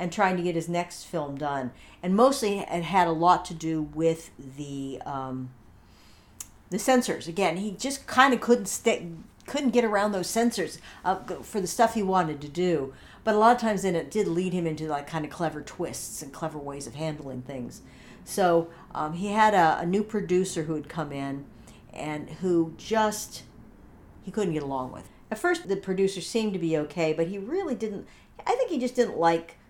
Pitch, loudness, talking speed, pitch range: 175 Hz, -27 LUFS, 205 wpm, 150-210 Hz